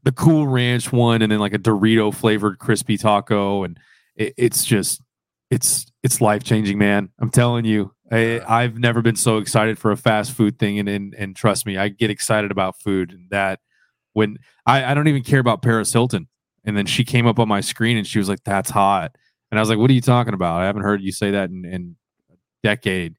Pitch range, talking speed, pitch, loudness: 100-120 Hz, 230 wpm, 110 Hz, -19 LUFS